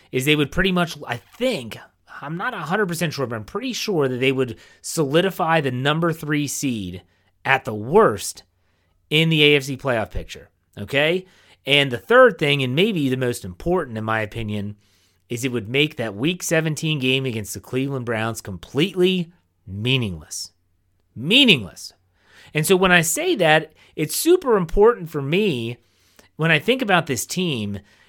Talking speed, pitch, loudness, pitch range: 160 wpm, 135 Hz, -20 LUFS, 110-170 Hz